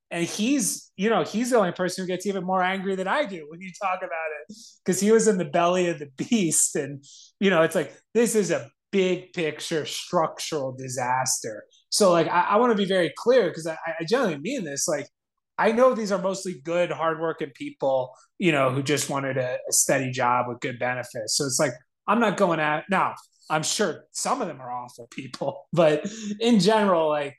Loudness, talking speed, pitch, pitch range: -24 LUFS, 215 wpm, 175 Hz, 150-205 Hz